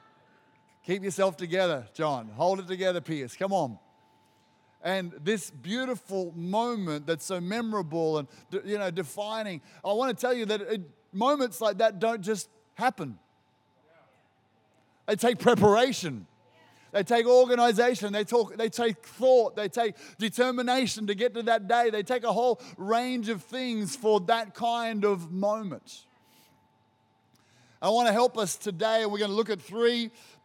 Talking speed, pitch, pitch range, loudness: 150 wpm, 205 Hz, 160-230 Hz, -28 LUFS